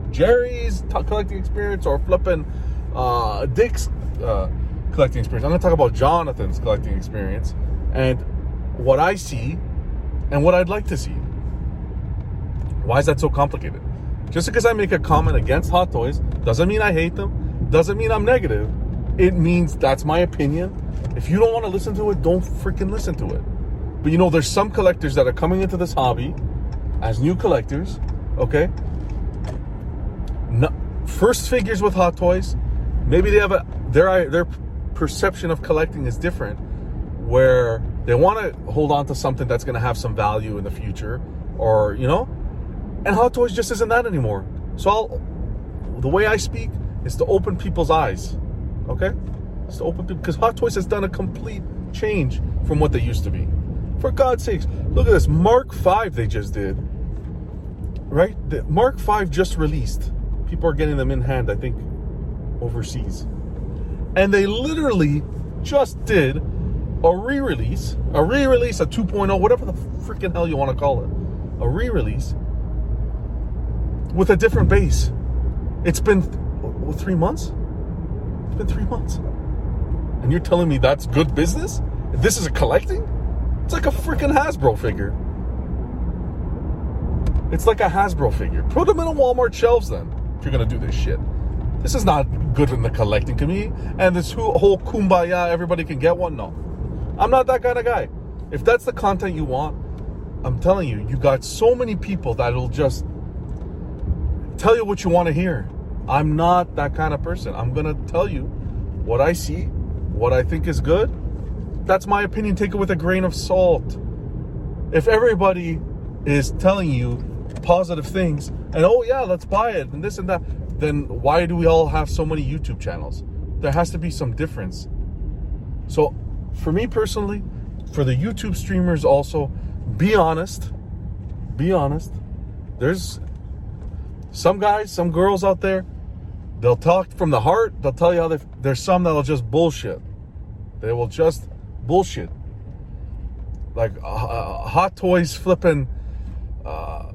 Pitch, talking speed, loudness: 120 Hz, 170 wpm, -21 LUFS